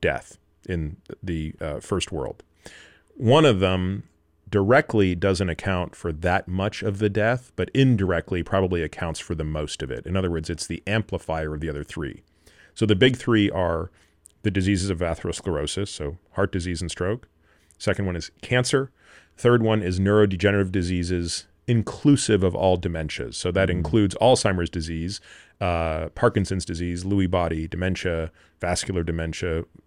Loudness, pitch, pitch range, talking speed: -24 LUFS, 90 Hz, 85-100 Hz, 155 wpm